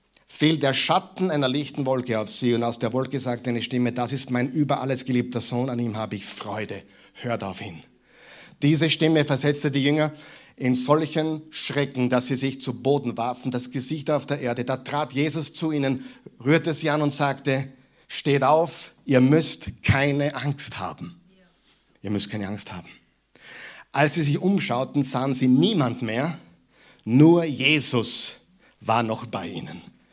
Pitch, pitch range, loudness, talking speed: 135 Hz, 120-150 Hz, -23 LUFS, 170 wpm